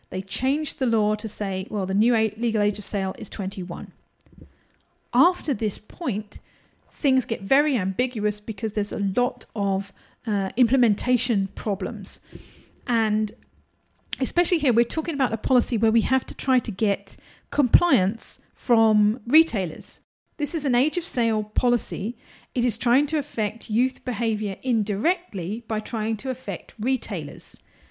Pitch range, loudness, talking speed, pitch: 210-260 Hz, -24 LUFS, 145 wpm, 230 Hz